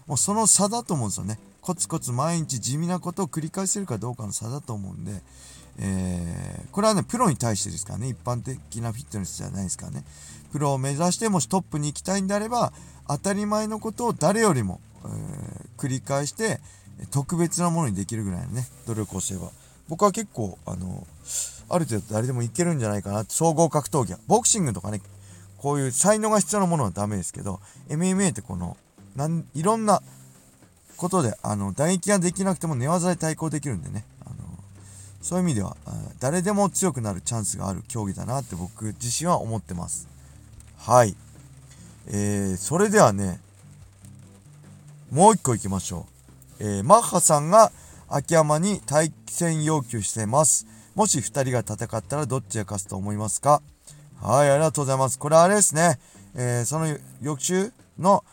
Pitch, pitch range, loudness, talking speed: 130 Hz, 100-170 Hz, -24 LUFS, 370 characters per minute